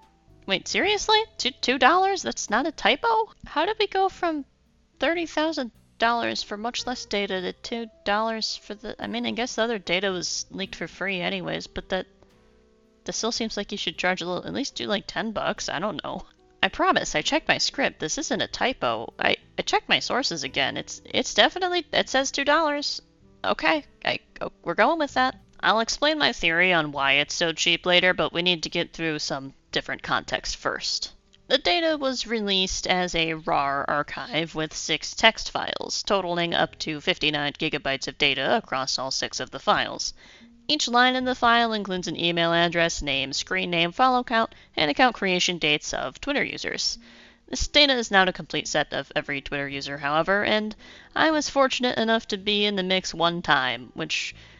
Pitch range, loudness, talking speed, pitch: 165-250 Hz, -24 LUFS, 190 wpm, 195 Hz